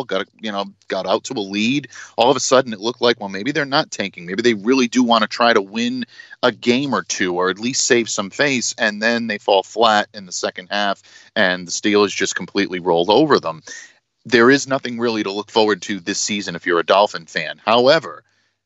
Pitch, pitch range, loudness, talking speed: 115 Hz, 100-125 Hz, -18 LUFS, 235 wpm